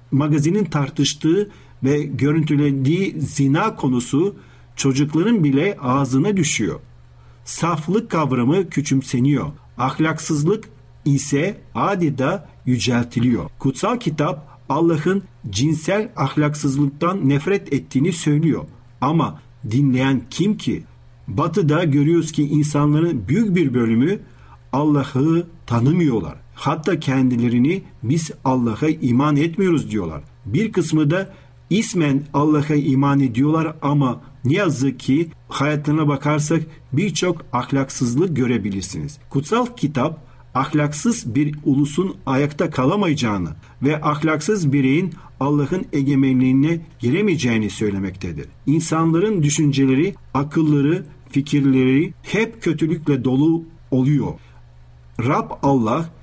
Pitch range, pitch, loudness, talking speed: 130-160 Hz, 145 Hz, -19 LUFS, 90 wpm